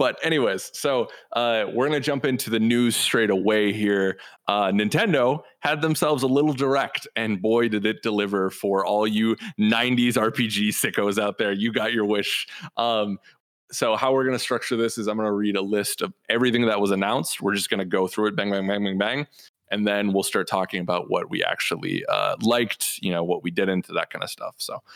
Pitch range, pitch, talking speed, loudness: 100-120 Hz, 110 Hz, 210 wpm, -23 LUFS